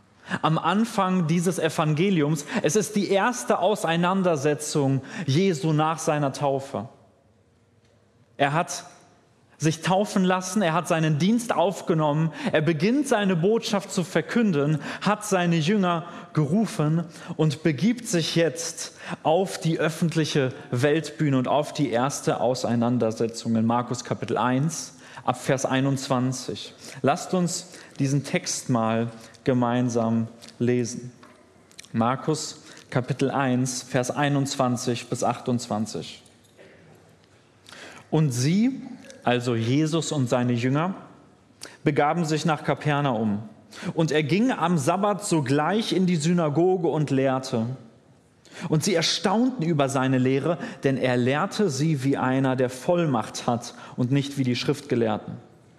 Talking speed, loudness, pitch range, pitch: 115 wpm, -24 LUFS, 130-175 Hz, 150 Hz